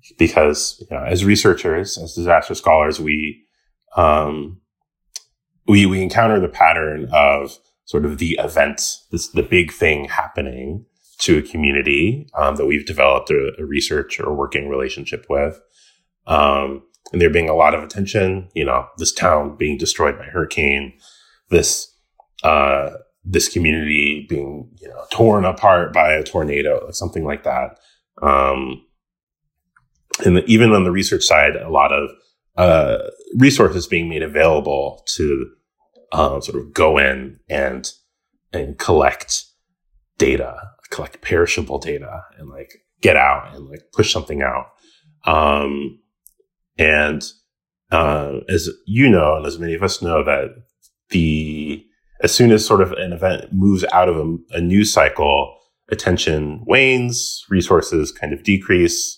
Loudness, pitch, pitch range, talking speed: -17 LUFS, 85 Hz, 75-110 Hz, 145 wpm